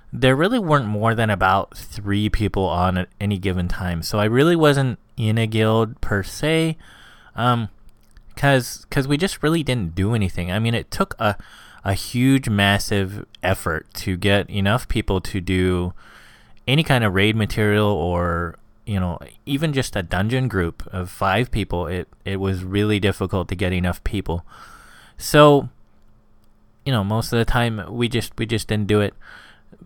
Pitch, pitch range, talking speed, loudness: 105 Hz, 95-115 Hz, 170 wpm, -21 LUFS